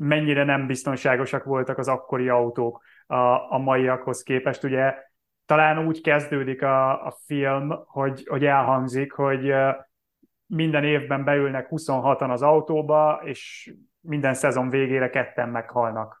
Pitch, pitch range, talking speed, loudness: 135 Hz, 130-145 Hz, 120 wpm, -23 LUFS